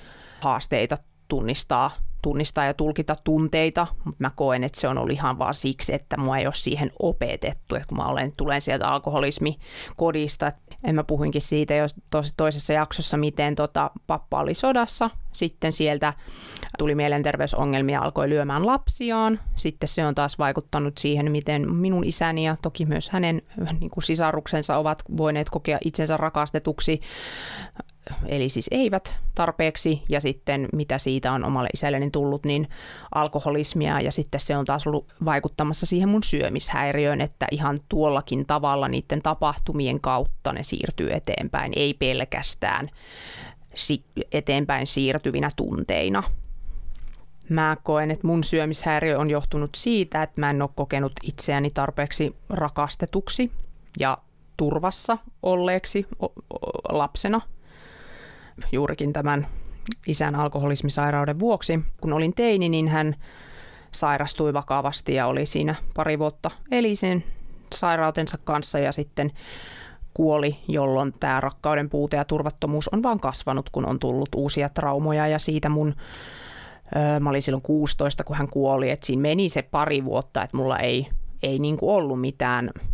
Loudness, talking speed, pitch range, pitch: -24 LUFS, 135 wpm, 140-160 Hz, 150 Hz